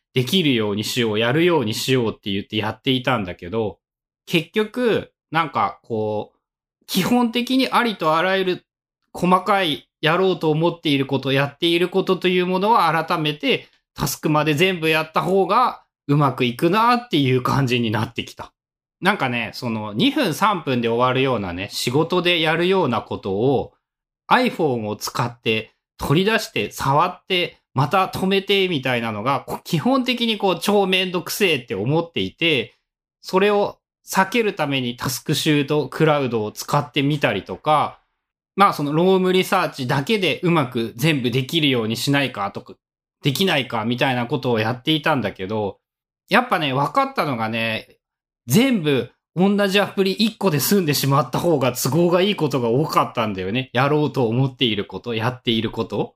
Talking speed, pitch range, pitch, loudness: 350 characters per minute, 120-185 Hz, 145 Hz, -20 LUFS